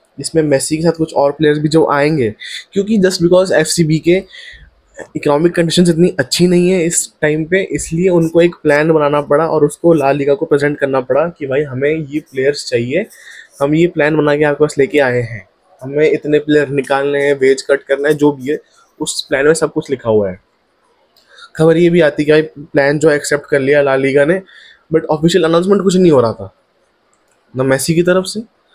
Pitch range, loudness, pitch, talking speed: 140-170 Hz, -13 LUFS, 150 Hz, 215 wpm